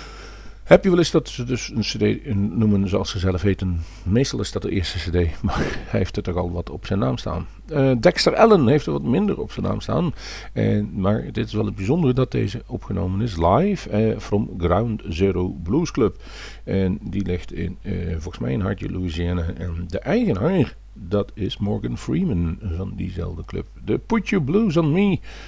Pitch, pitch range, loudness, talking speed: 100 Hz, 90-120 Hz, -22 LUFS, 200 wpm